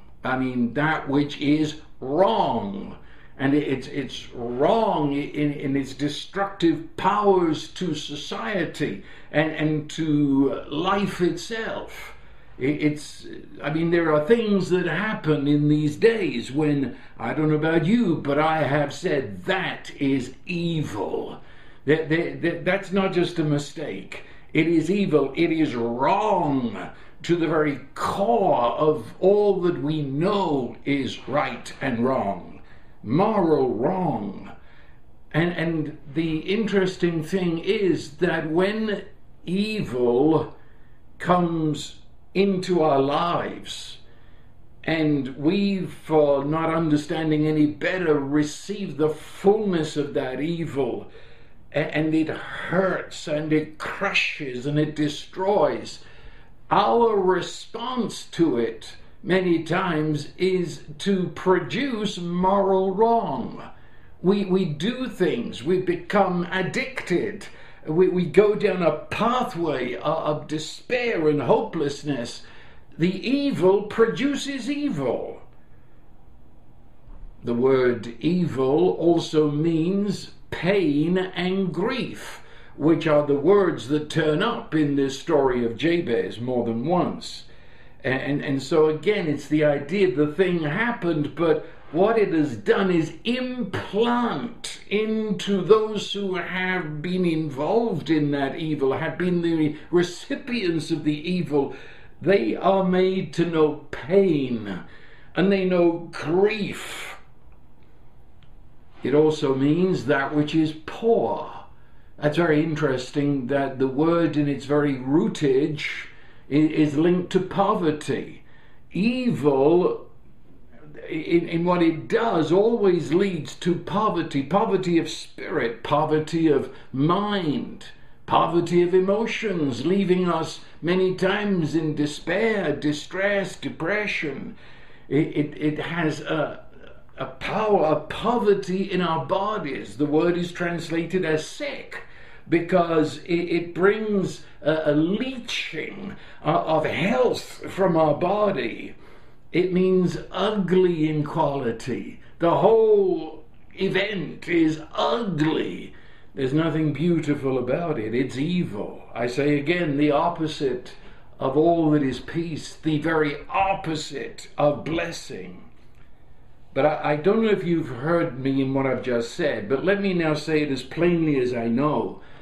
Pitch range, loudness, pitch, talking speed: 150-185 Hz, -23 LUFS, 160 Hz, 120 wpm